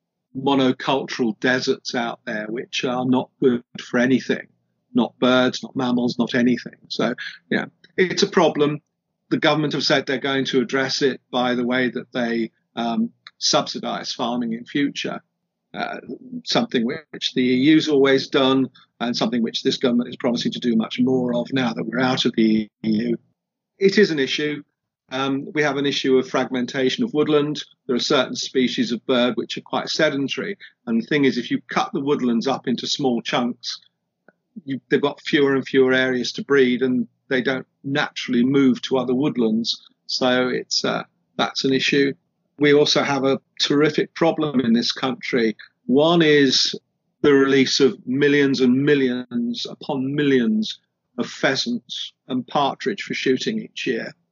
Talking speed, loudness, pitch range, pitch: 170 wpm, -21 LUFS, 125-150 Hz, 135 Hz